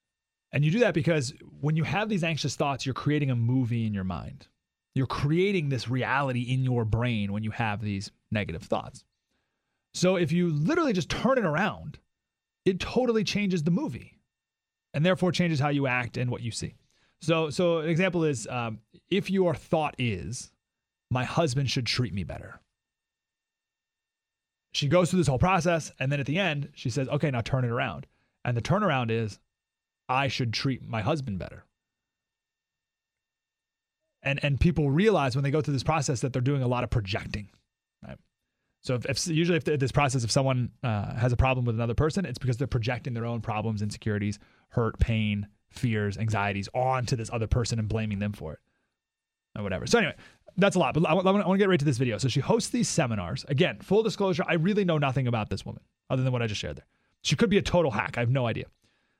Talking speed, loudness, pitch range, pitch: 205 wpm, -27 LUFS, 115-165 Hz, 135 Hz